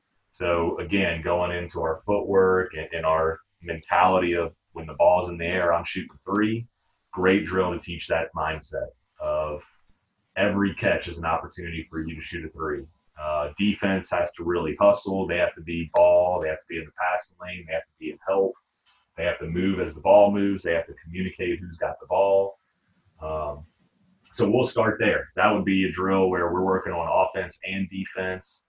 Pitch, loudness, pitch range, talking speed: 90 Hz, -25 LUFS, 85-95 Hz, 205 wpm